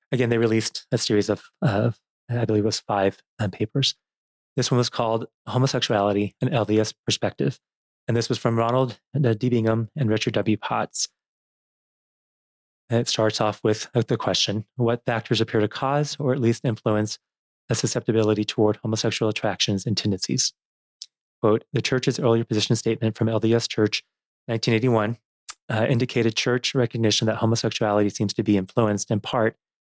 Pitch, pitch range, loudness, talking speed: 115 Hz, 105-125 Hz, -23 LUFS, 160 wpm